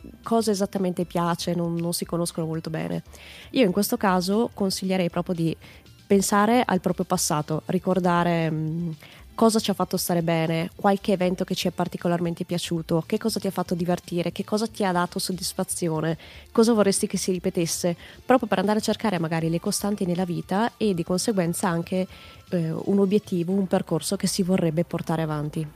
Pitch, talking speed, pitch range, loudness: 185 Hz, 175 wpm, 170-200 Hz, -24 LUFS